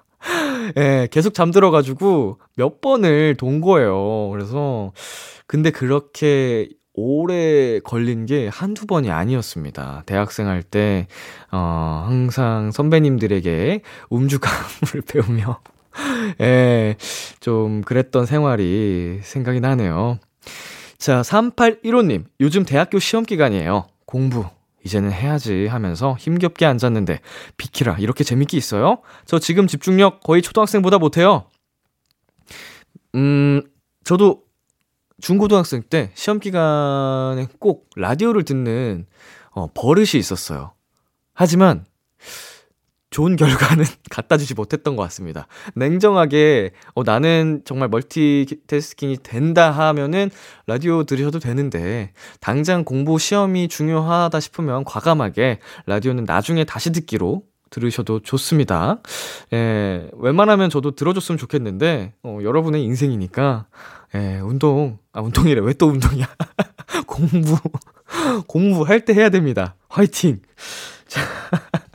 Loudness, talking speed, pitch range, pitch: -18 LUFS, 260 characters per minute, 115-165 Hz, 140 Hz